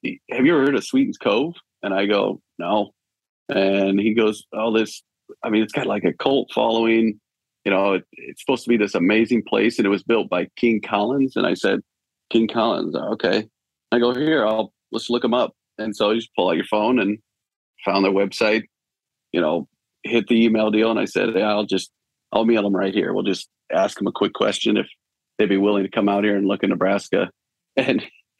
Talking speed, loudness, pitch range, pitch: 220 wpm, -21 LUFS, 100-115 Hz, 110 Hz